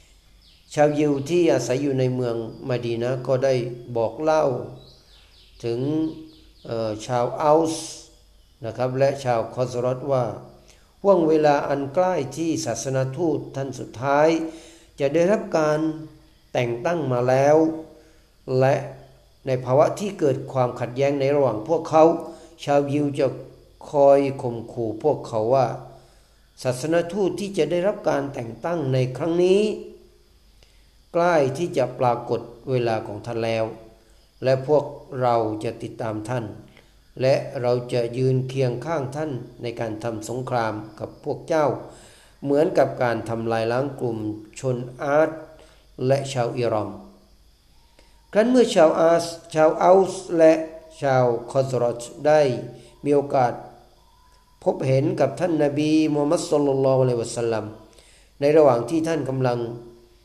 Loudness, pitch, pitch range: -22 LUFS, 130 Hz, 120-155 Hz